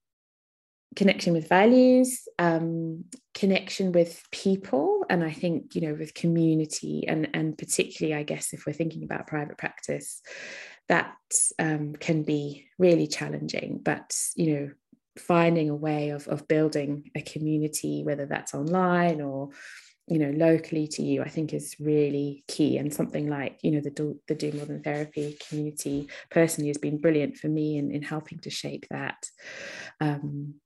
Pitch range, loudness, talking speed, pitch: 145-170 Hz, -27 LUFS, 160 wpm, 155 Hz